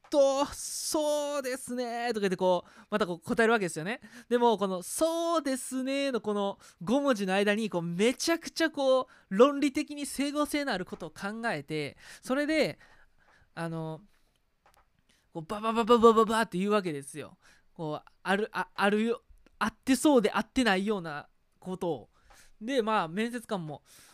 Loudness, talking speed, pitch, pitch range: -29 LUFS, 315 characters per minute, 225 Hz, 185-265 Hz